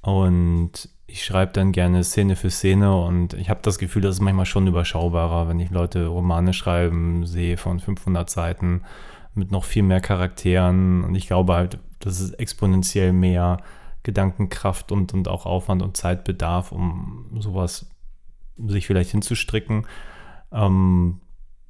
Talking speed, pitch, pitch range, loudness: 145 wpm, 95 Hz, 90-95 Hz, -22 LUFS